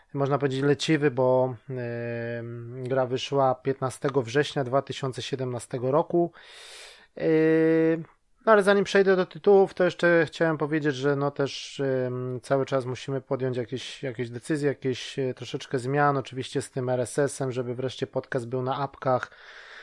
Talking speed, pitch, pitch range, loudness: 140 wpm, 135 Hz, 130-155 Hz, -26 LUFS